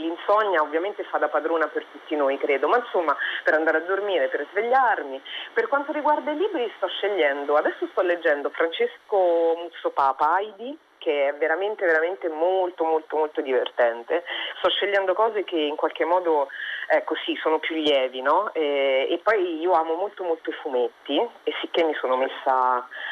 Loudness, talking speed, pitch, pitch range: -24 LUFS, 170 wpm, 165 Hz, 150-215 Hz